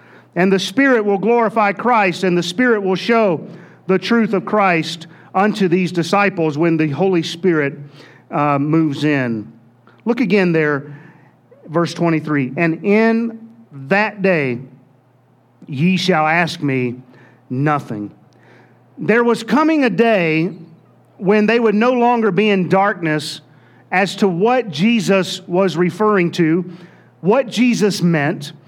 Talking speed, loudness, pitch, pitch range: 130 wpm, -16 LUFS, 175 Hz, 150-205 Hz